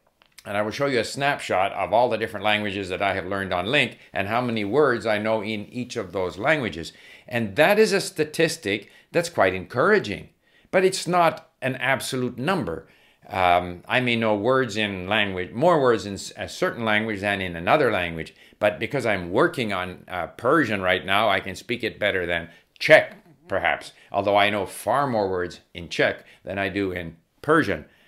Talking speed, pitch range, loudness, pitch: 190 wpm, 100-130 Hz, -23 LUFS, 110 Hz